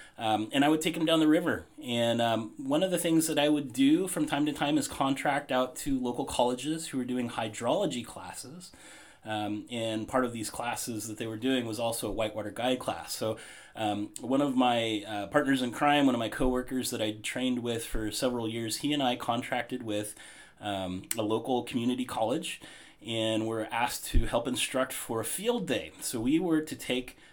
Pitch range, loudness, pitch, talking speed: 110-145 Hz, -30 LUFS, 125 Hz, 210 wpm